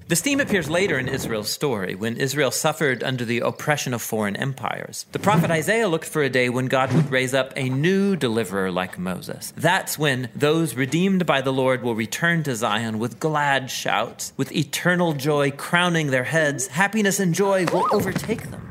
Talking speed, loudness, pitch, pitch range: 190 wpm, -22 LUFS, 145 Hz, 130-170 Hz